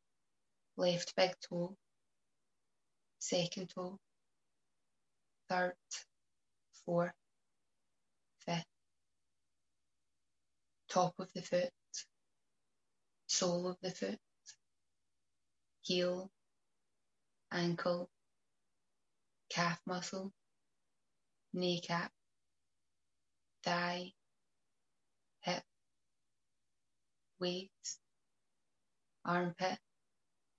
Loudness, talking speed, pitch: -39 LUFS, 50 wpm, 170 Hz